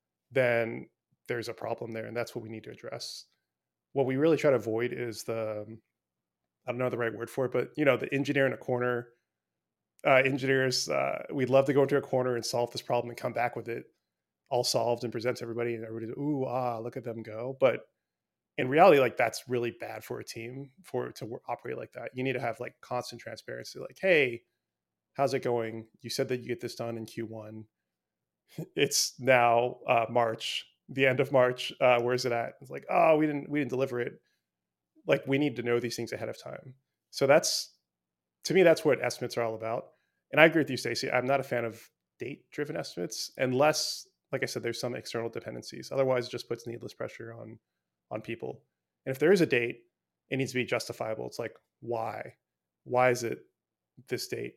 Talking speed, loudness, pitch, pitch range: 220 wpm, -29 LUFS, 120 Hz, 115-130 Hz